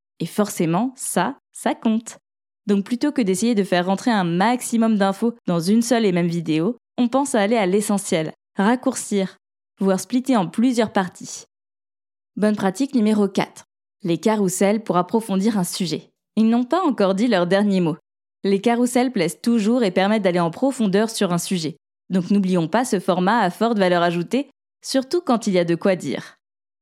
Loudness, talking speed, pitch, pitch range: -20 LUFS, 180 wpm, 200 Hz, 180-235 Hz